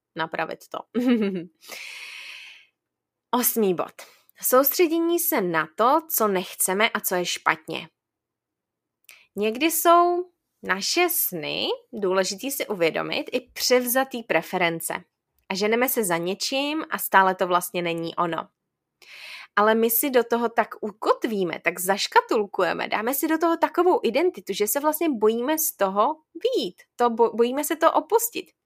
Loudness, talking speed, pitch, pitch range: -23 LUFS, 130 wpm, 235 Hz, 195-320 Hz